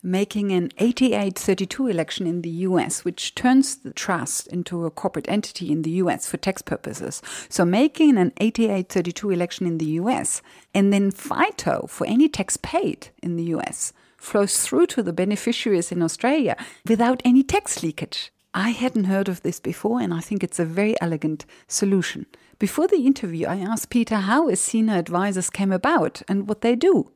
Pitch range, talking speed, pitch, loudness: 175-235 Hz, 175 wpm, 195 Hz, -22 LUFS